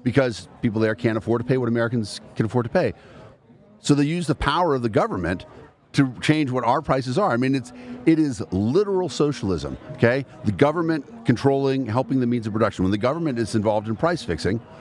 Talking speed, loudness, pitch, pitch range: 205 wpm, -22 LUFS, 125 Hz, 115-145 Hz